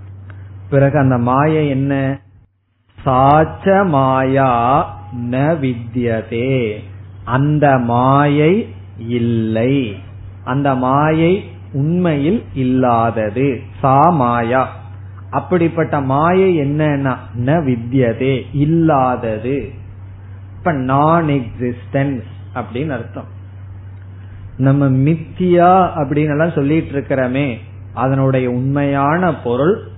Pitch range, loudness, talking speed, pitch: 110-145 Hz, -15 LUFS, 65 wpm, 130 Hz